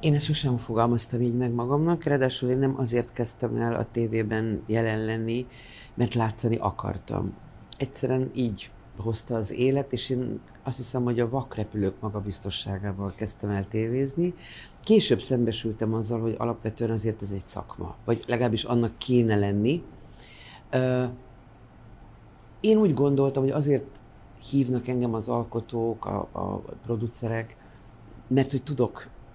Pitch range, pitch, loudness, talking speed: 110-125 Hz, 115 Hz, -27 LUFS, 135 wpm